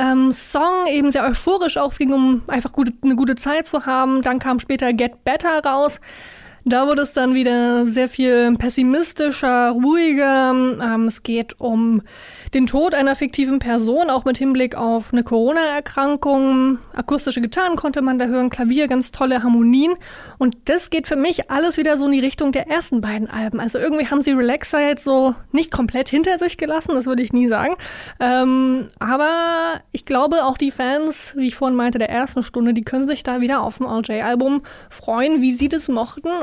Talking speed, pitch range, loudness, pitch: 190 wpm, 245-290 Hz, -18 LUFS, 265 Hz